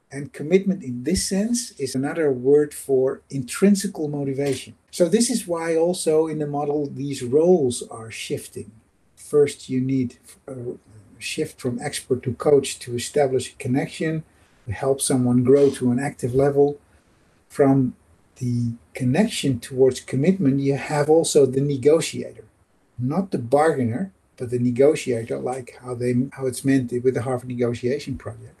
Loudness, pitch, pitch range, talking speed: -22 LUFS, 135 Hz, 125-145 Hz, 150 wpm